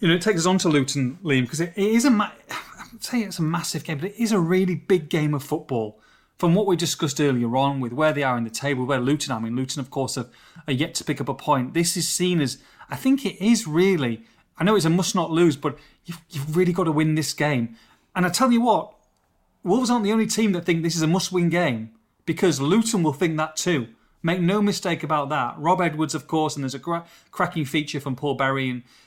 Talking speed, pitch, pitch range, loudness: 255 wpm, 160 Hz, 140-180 Hz, -23 LUFS